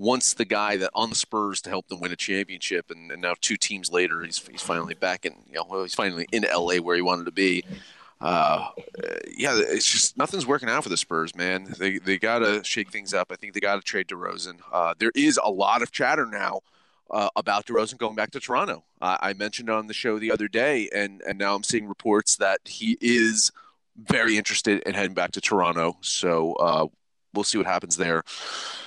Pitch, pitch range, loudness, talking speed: 100 Hz, 95-110 Hz, -24 LUFS, 220 wpm